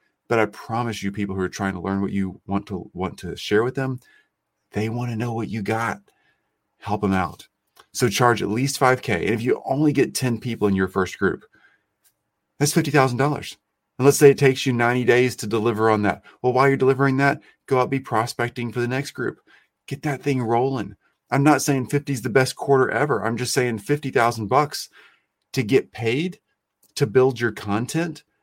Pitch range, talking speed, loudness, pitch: 110-135 Hz, 205 wpm, -22 LUFS, 125 Hz